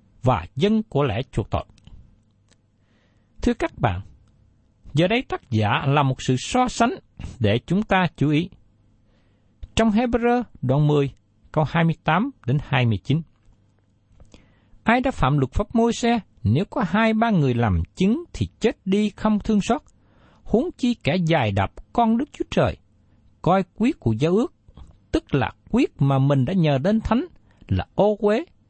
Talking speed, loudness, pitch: 160 wpm, -22 LUFS, 140 Hz